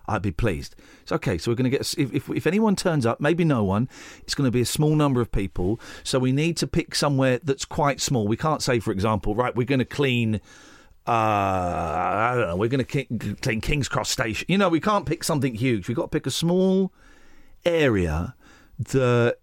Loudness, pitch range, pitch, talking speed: -24 LUFS, 110-150 Hz, 130 Hz, 230 wpm